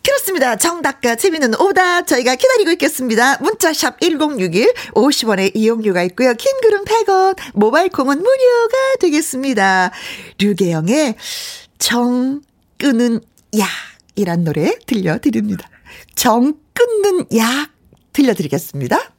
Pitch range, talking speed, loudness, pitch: 225-365 Hz, 265 characters per minute, -15 LUFS, 275 Hz